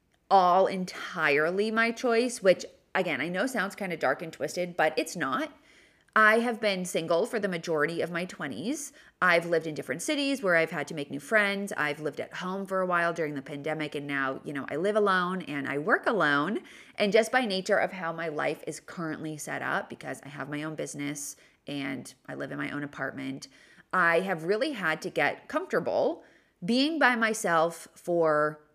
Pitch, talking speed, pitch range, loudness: 170 Hz, 200 wpm, 150-205 Hz, -28 LUFS